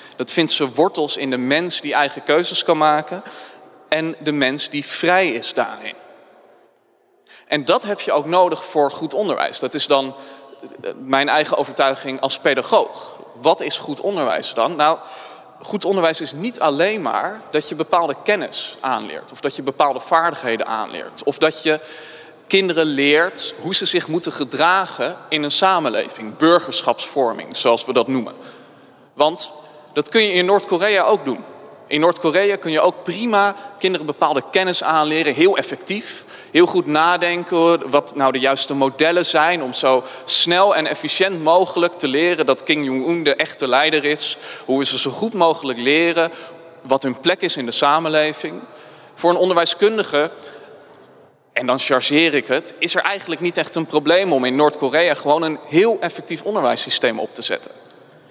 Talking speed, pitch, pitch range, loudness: 165 wpm, 160 Hz, 145-180 Hz, -17 LUFS